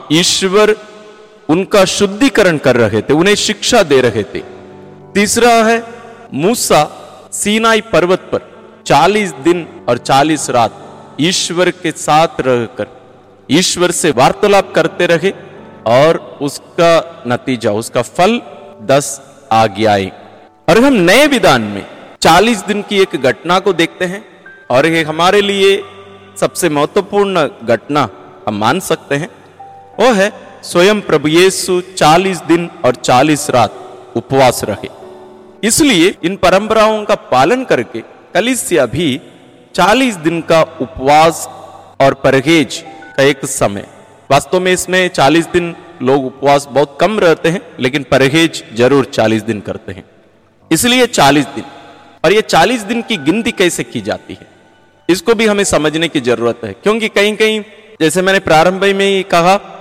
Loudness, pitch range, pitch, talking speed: -12 LUFS, 135-200 Hz, 170 Hz, 140 wpm